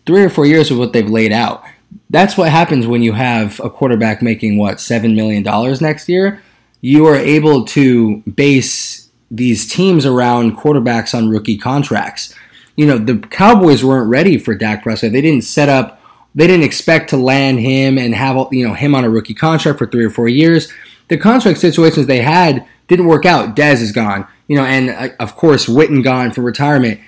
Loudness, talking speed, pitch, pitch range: -11 LUFS, 200 wpm, 130 Hz, 115-155 Hz